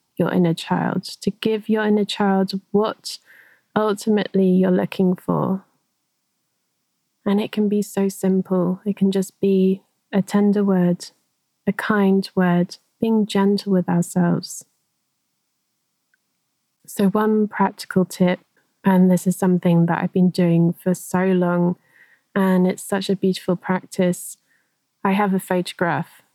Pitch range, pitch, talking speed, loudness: 180-200 Hz, 190 Hz, 130 wpm, -20 LUFS